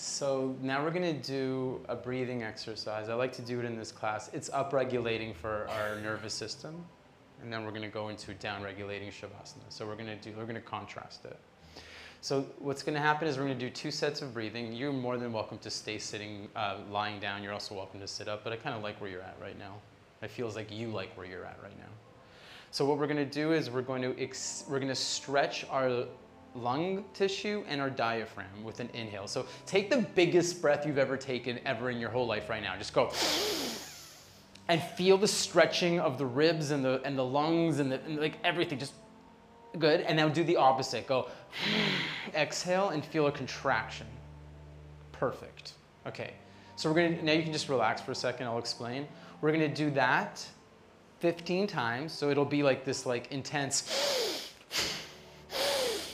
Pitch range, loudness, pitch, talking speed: 110-150 Hz, -32 LUFS, 130 Hz, 195 wpm